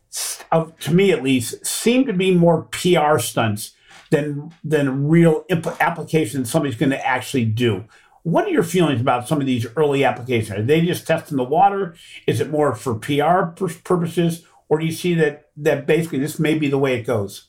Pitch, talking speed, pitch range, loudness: 150 Hz, 195 wpm, 130-165 Hz, -19 LUFS